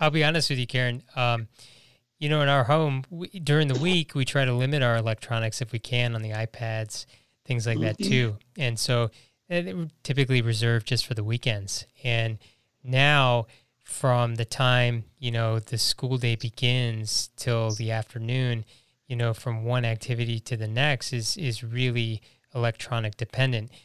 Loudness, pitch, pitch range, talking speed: -26 LUFS, 120 Hz, 115-130 Hz, 170 wpm